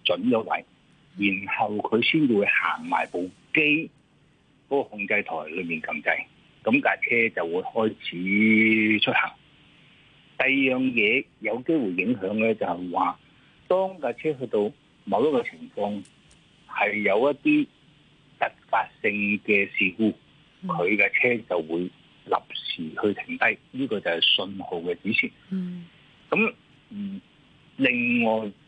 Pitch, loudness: 130 Hz, -24 LUFS